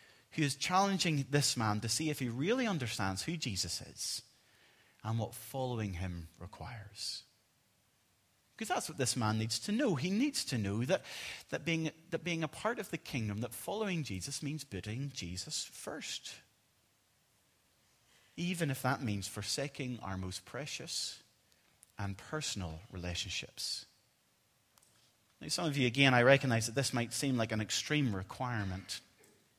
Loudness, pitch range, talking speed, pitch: -36 LUFS, 105-155 Hz, 150 wpm, 125 Hz